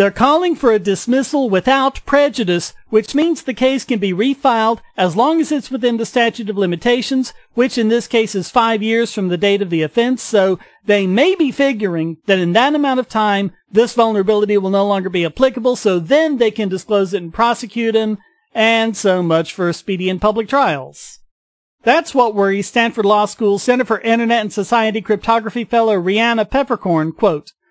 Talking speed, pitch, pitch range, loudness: 190 wpm, 225 Hz, 195-245 Hz, -15 LUFS